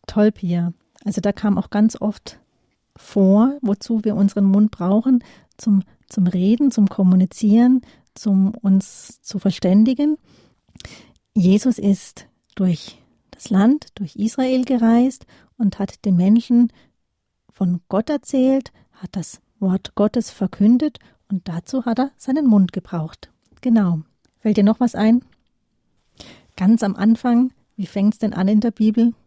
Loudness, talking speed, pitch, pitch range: -19 LUFS, 135 wpm, 210 Hz, 195-240 Hz